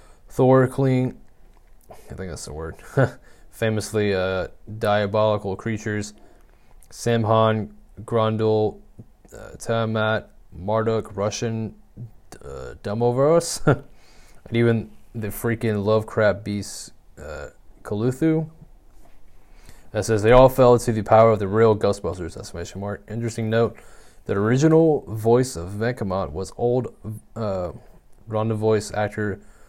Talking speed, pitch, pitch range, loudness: 110 wpm, 110 Hz, 100-115 Hz, -22 LUFS